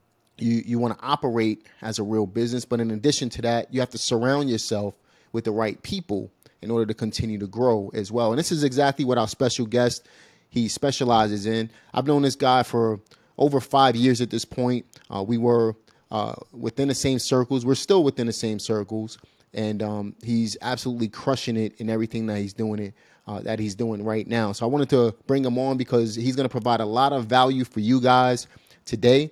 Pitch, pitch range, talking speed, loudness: 115 Hz, 110-130 Hz, 215 wpm, -24 LUFS